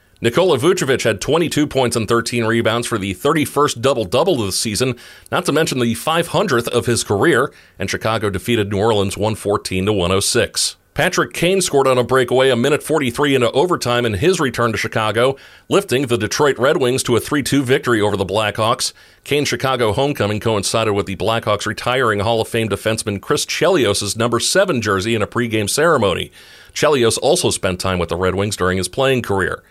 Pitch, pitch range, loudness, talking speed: 115 Hz, 100-130 Hz, -17 LUFS, 190 wpm